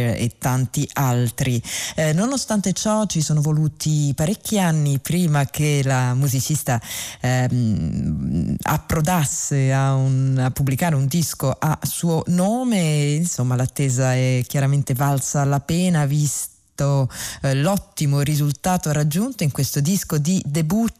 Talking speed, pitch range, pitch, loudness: 125 wpm, 130-165 Hz, 145 Hz, -20 LUFS